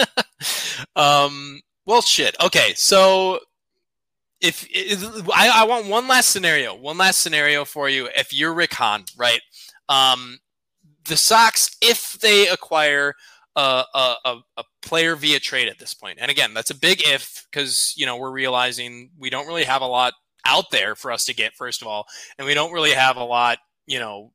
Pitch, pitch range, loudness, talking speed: 145 Hz, 130-190 Hz, -18 LUFS, 180 wpm